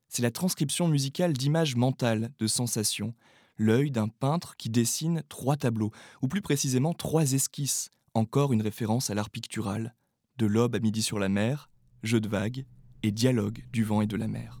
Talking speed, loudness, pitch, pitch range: 180 wpm, -28 LUFS, 120 Hz, 110-140 Hz